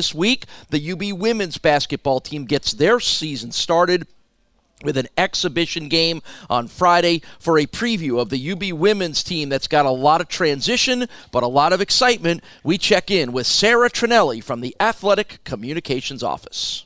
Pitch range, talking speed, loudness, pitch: 140-200 Hz, 165 wpm, -19 LUFS, 165 Hz